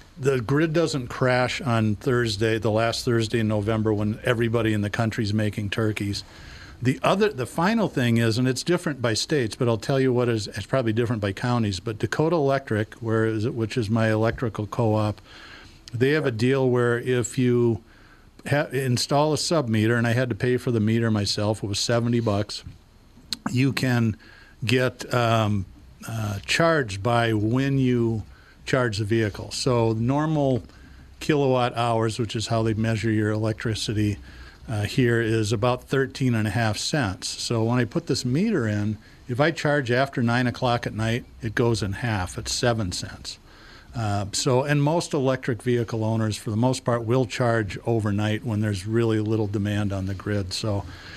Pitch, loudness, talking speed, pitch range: 115 Hz, -24 LUFS, 180 wpm, 110-125 Hz